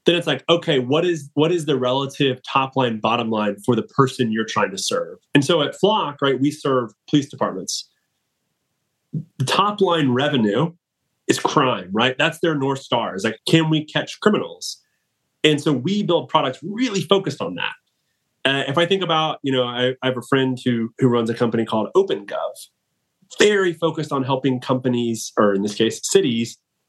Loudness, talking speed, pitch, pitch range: -20 LUFS, 190 wpm, 140 Hz, 125-165 Hz